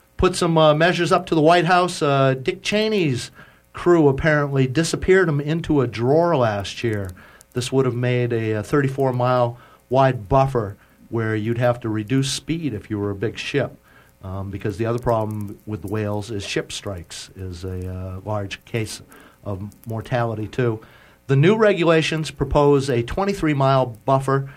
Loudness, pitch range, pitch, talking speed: -20 LUFS, 110-150 Hz, 125 Hz, 160 wpm